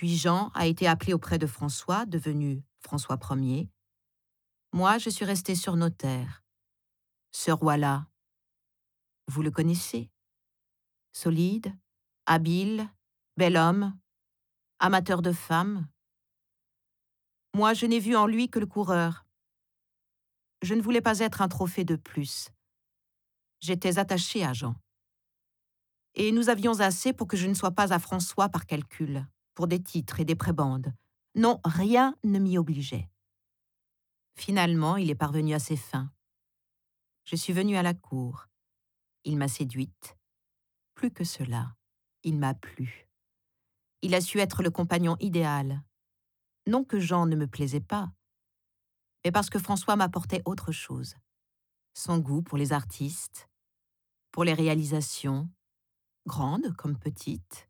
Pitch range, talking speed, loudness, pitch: 130-185 Hz, 135 wpm, -28 LUFS, 165 Hz